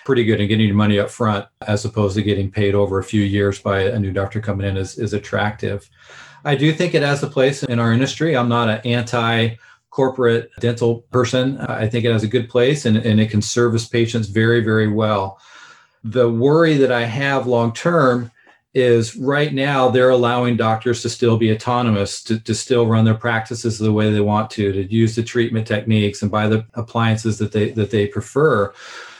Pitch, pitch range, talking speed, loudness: 115 Hz, 105-120 Hz, 205 wpm, -18 LUFS